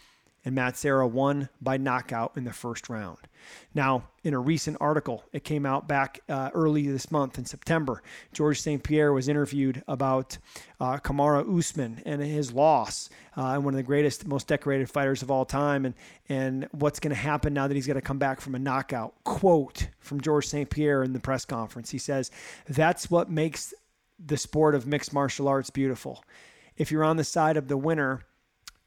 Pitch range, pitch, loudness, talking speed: 130-150 Hz, 140 Hz, -28 LUFS, 195 wpm